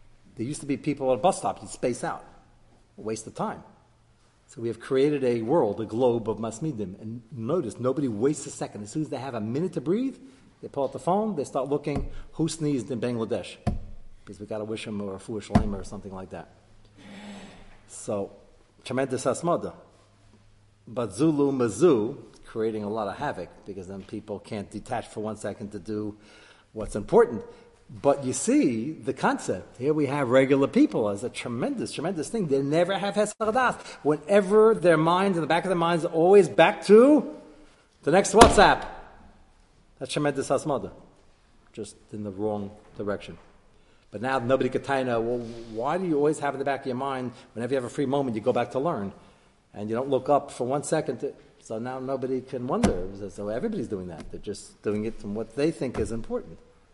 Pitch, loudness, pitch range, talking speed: 130 Hz, -26 LUFS, 110-150 Hz, 200 wpm